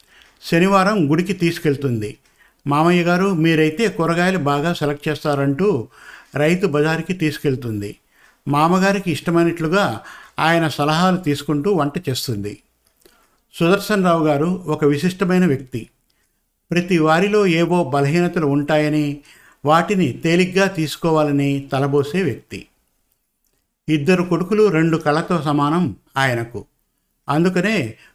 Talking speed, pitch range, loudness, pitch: 90 wpm, 145-180 Hz, -18 LUFS, 160 Hz